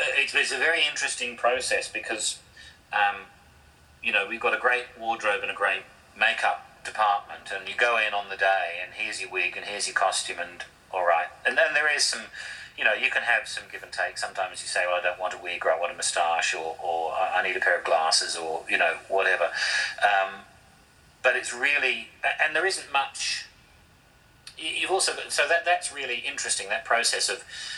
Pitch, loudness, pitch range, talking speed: 95 Hz, -25 LUFS, 90-115 Hz, 205 wpm